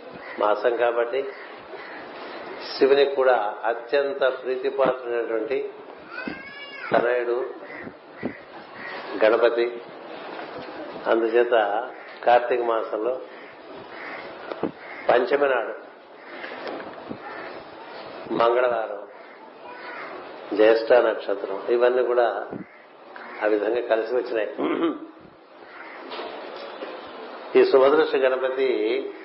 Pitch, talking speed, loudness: 125 Hz, 50 wpm, -23 LUFS